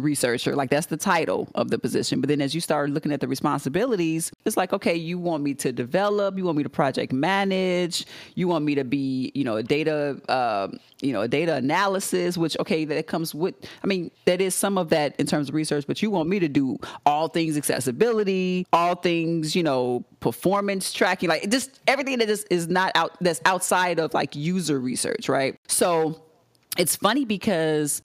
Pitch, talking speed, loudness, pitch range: 170 Hz, 205 wpm, -24 LUFS, 150-185 Hz